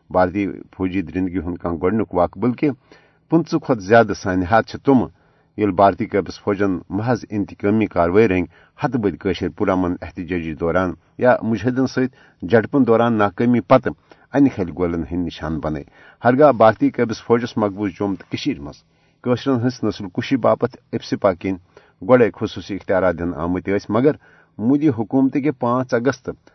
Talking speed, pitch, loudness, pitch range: 140 wpm, 105 Hz, -19 LUFS, 90-125 Hz